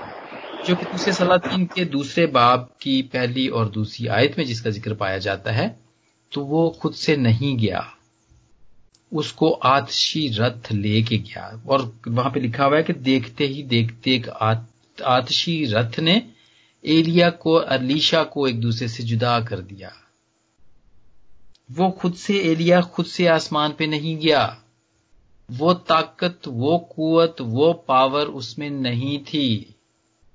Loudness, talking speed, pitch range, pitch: -21 LUFS, 140 wpm, 115-160 Hz, 135 Hz